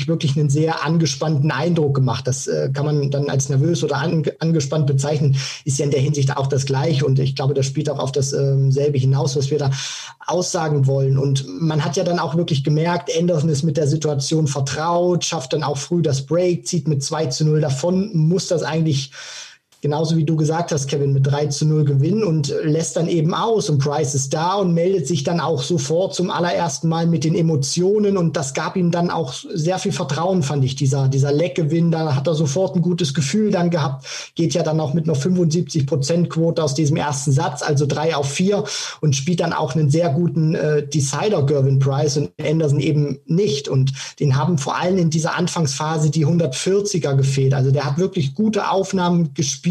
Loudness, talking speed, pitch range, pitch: -19 LUFS, 210 wpm, 145-170 Hz, 155 Hz